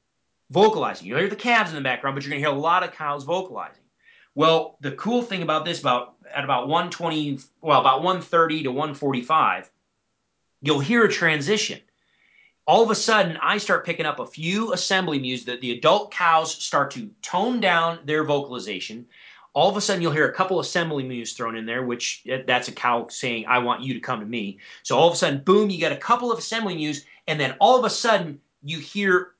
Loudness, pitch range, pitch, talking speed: -22 LUFS, 130-190 Hz, 155 Hz, 220 wpm